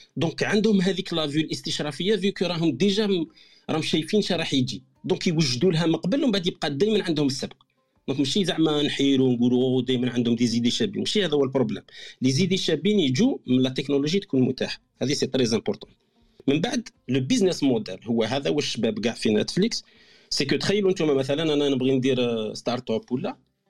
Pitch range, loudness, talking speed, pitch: 130-190 Hz, -24 LUFS, 185 wpm, 155 Hz